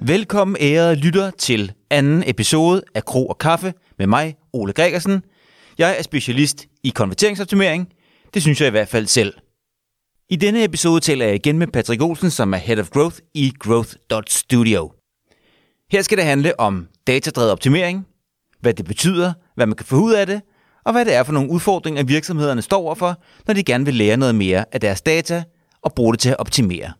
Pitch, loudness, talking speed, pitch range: 145 Hz, -18 LUFS, 190 wpm, 115-175 Hz